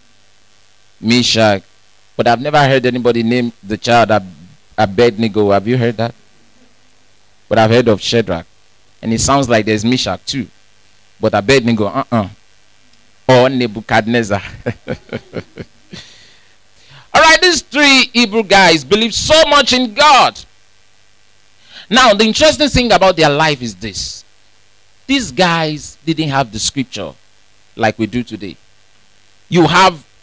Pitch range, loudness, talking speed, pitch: 105-145 Hz, -12 LUFS, 130 wpm, 115 Hz